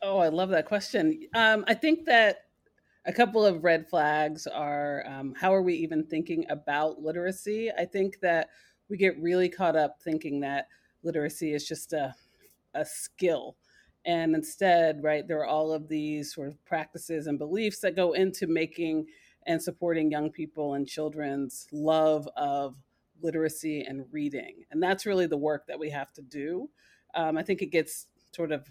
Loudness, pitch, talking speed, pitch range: -29 LUFS, 160 Hz, 175 wpm, 150-185 Hz